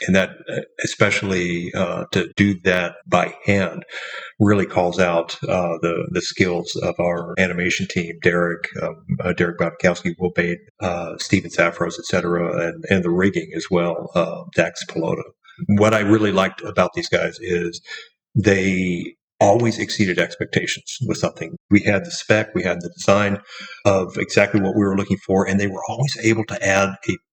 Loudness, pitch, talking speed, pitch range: -20 LUFS, 95 Hz, 165 wpm, 85-100 Hz